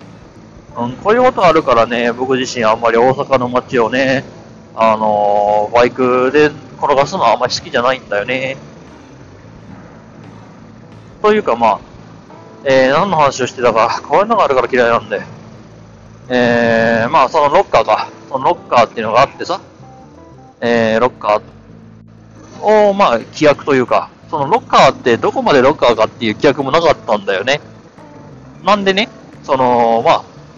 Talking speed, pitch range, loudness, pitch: 325 characters per minute, 110-135 Hz, -13 LUFS, 120 Hz